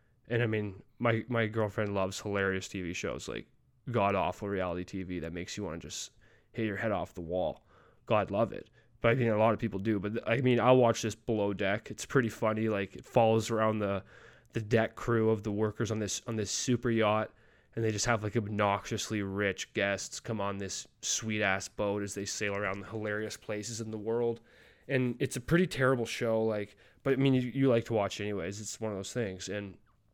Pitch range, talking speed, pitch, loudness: 100-115 Hz, 225 wpm, 110 Hz, -32 LUFS